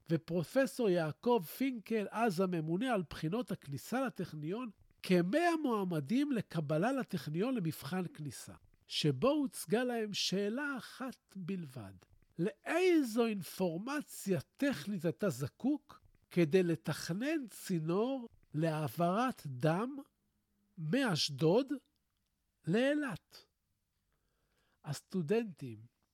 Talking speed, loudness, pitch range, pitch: 80 wpm, -36 LUFS, 160-245 Hz, 190 Hz